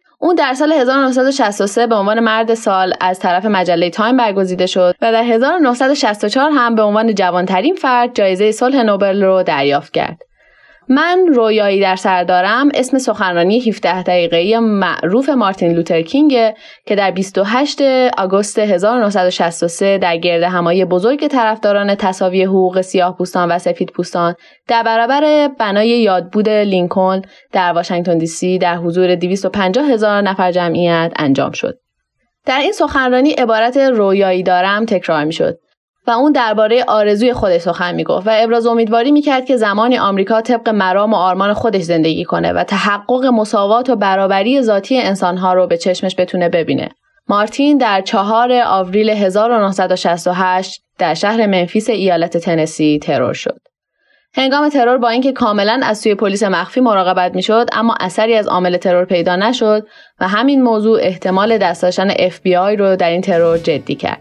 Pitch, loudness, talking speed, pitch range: 205 Hz, -13 LUFS, 150 wpm, 185-235 Hz